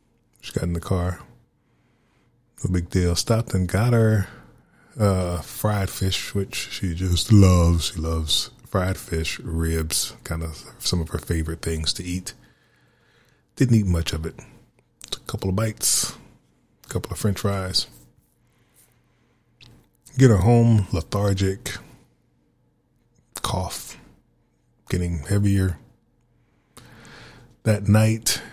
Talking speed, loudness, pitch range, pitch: 120 wpm, -23 LUFS, 80-105 Hz, 95 Hz